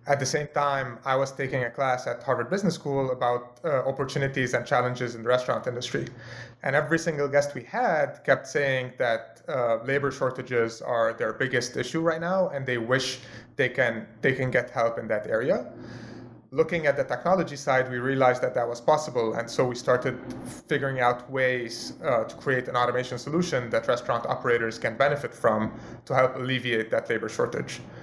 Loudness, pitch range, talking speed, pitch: -26 LUFS, 120-140 Hz, 190 wpm, 130 Hz